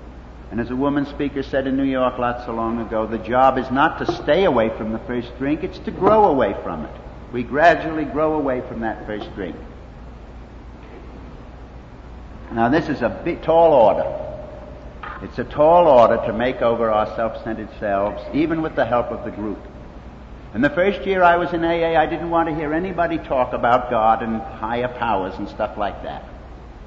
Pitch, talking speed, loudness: 120 Hz, 190 wpm, -19 LUFS